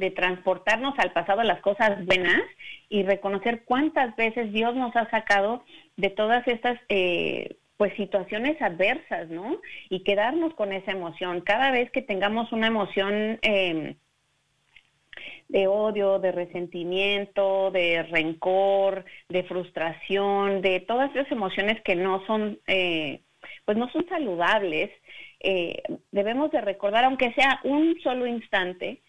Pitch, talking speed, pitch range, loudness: 200 Hz, 135 wpm, 190-235 Hz, -25 LUFS